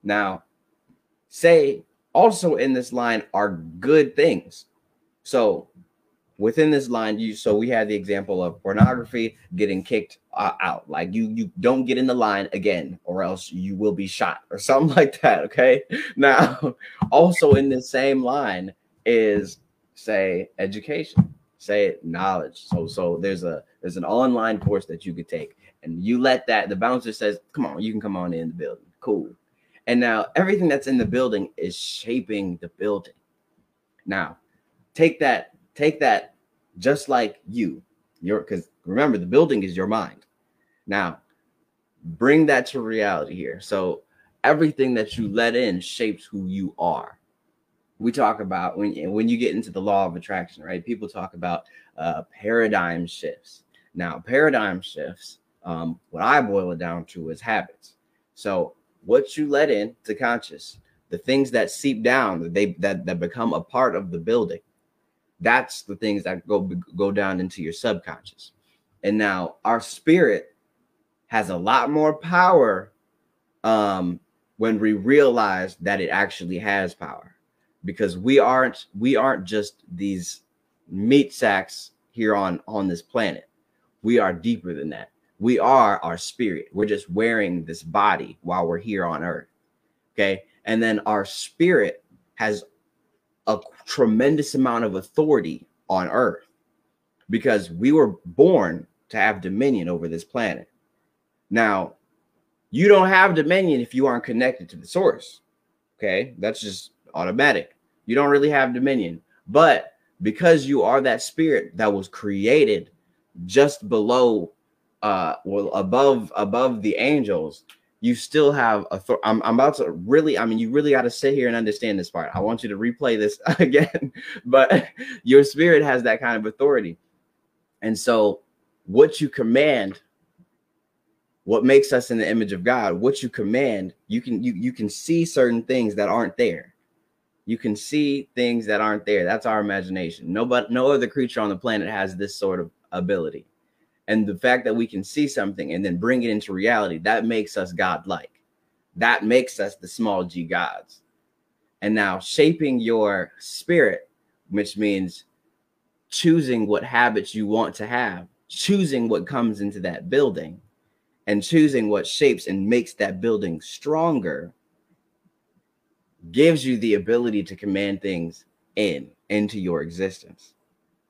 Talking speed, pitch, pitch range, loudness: 160 wpm, 110 Hz, 100-140 Hz, -21 LUFS